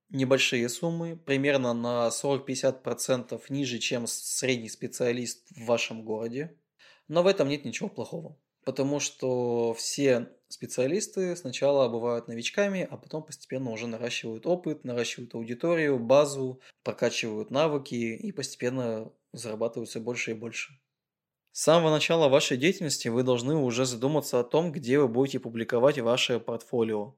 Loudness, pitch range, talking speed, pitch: -28 LUFS, 120-150 Hz, 130 wpm, 130 Hz